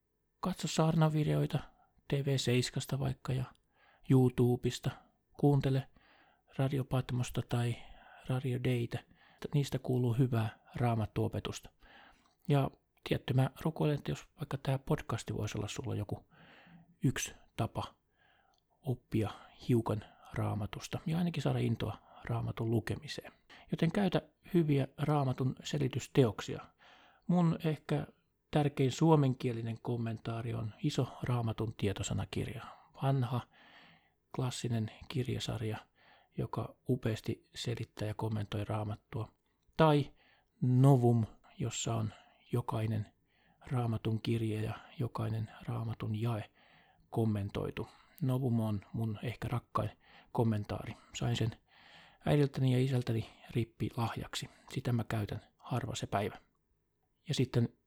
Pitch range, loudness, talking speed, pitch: 110-140 Hz, -35 LUFS, 100 wpm, 120 Hz